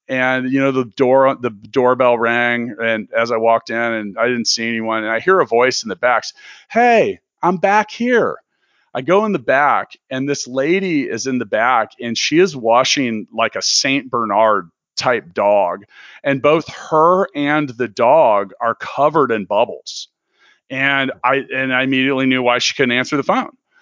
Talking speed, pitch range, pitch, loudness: 185 wpm, 115-150 Hz, 130 Hz, -16 LUFS